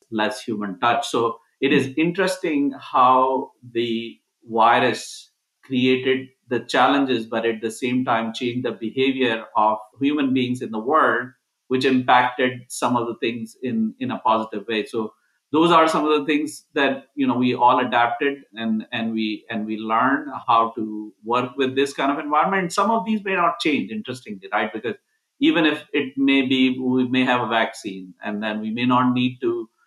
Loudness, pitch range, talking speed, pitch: -21 LUFS, 115-145 Hz, 185 wpm, 125 Hz